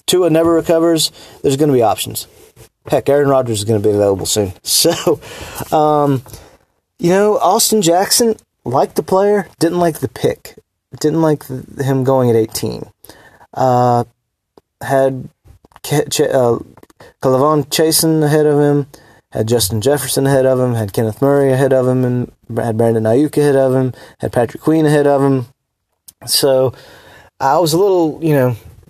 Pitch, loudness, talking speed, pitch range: 135 Hz, -14 LUFS, 160 wpm, 115-155 Hz